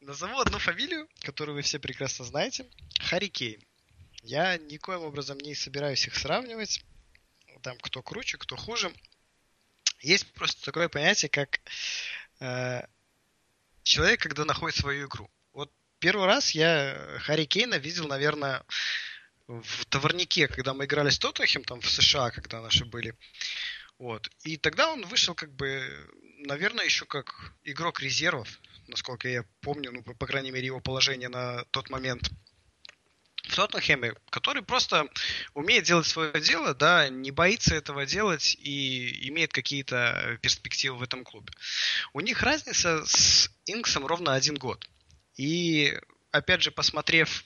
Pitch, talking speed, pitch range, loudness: 140 Hz, 135 wpm, 125-160 Hz, -27 LUFS